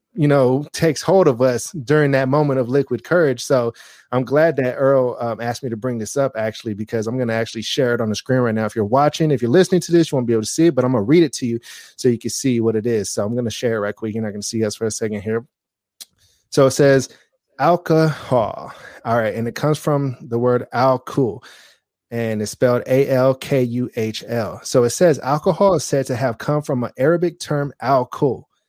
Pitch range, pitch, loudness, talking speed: 115-145 Hz, 130 Hz, -19 LUFS, 245 wpm